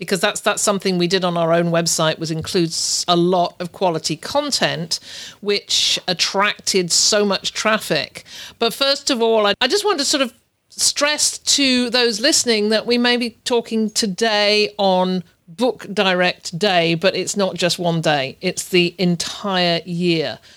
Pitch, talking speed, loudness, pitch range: 195 Hz, 165 wpm, -17 LUFS, 175-225 Hz